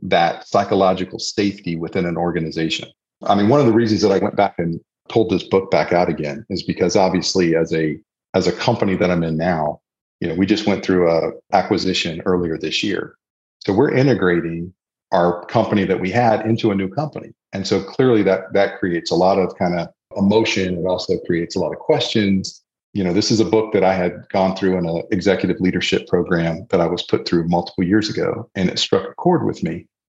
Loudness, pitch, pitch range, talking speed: -18 LUFS, 90 Hz, 85-105 Hz, 215 wpm